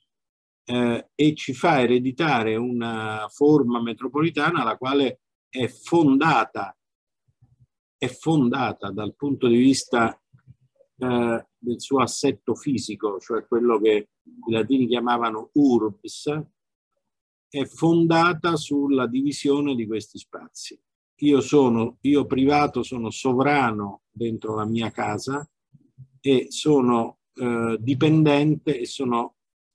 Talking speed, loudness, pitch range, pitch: 105 wpm, -22 LUFS, 115-145 Hz, 130 Hz